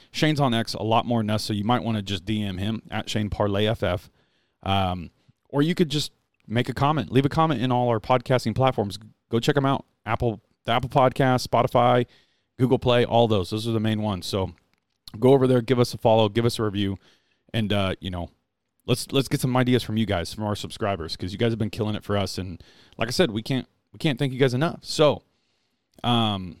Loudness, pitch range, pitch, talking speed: -24 LUFS, 105-130 Hz, 115 Hz, 235 wpm